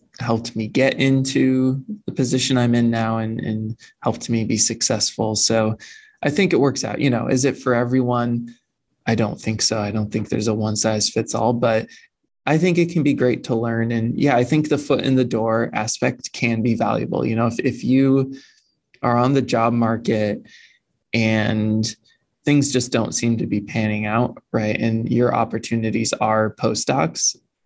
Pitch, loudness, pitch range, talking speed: 115 Hz, -20 LUFS, 110-130 Hz, 190 wpm